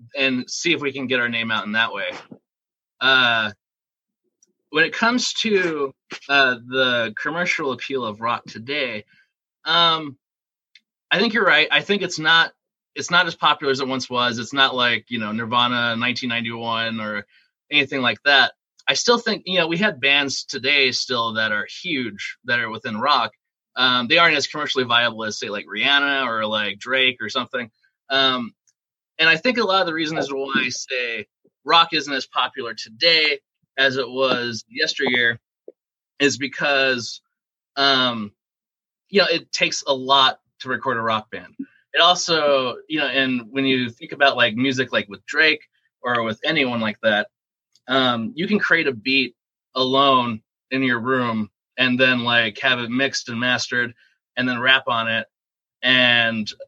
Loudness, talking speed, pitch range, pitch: -19 LUFS, 170 wpm, 120-150 Hz, 130 Hz